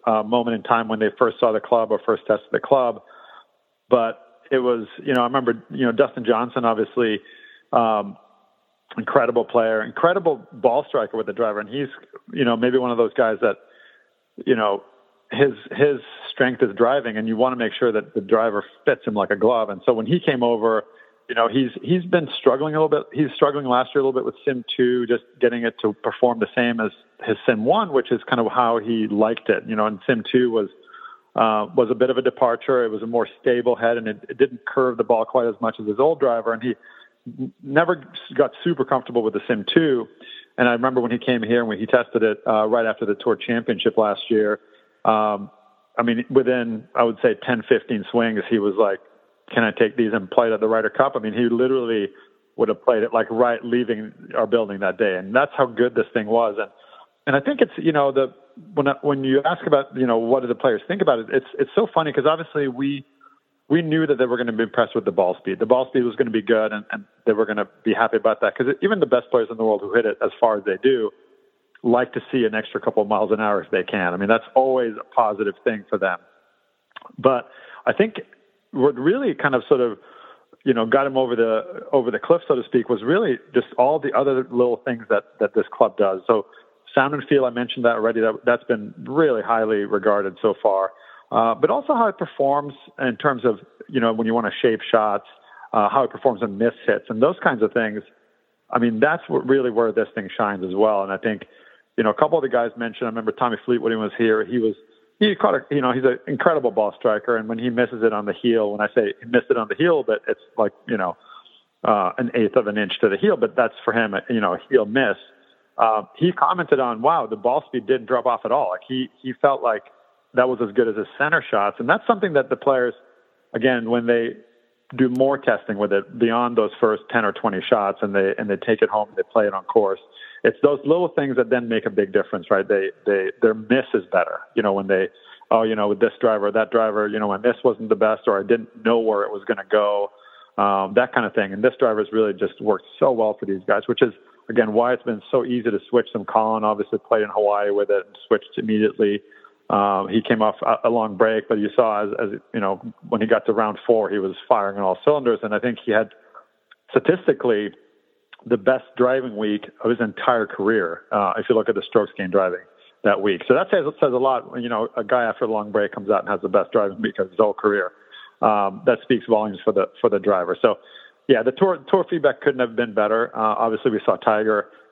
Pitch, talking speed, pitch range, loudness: 120 Hz, 250 wpm, 110-140 Hz, -21 LUFS